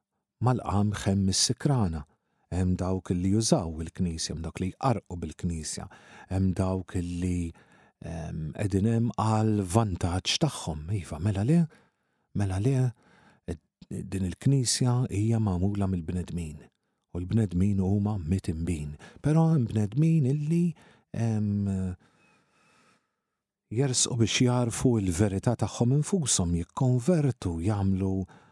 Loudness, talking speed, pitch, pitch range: -28 LUFS, 100 wpm, 100 Hz, 90-120 Hz